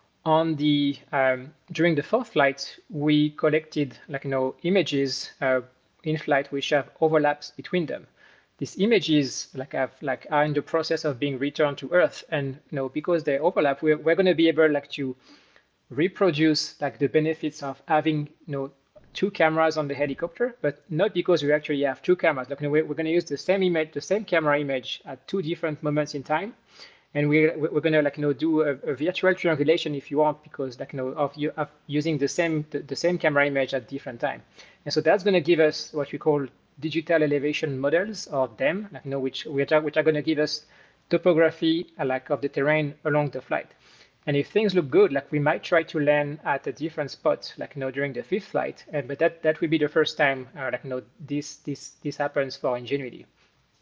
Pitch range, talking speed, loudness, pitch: 140-160 Hz, 220 wpm, -25 LUFS, 150 Hz